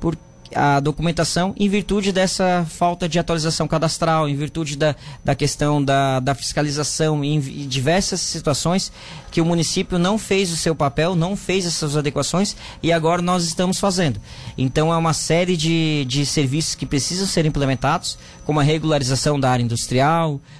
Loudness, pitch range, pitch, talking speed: -20 LUFS, 145-175 Hz, 160 Hz, 155 wpm